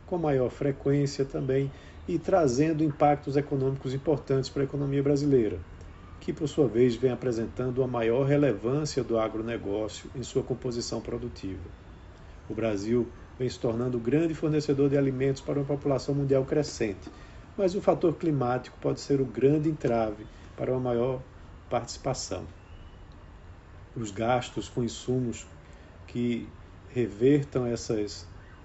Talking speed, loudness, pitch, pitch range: 130 wpm, -28 LUFS, 125 Hz, 110-140 Hz